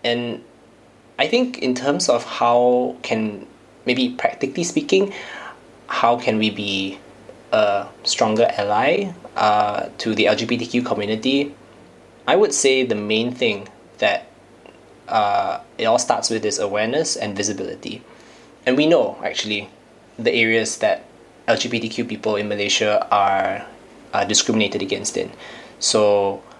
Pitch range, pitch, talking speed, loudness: 105-125 Hz, 115 Hz, 125 wpm, -20 LUFS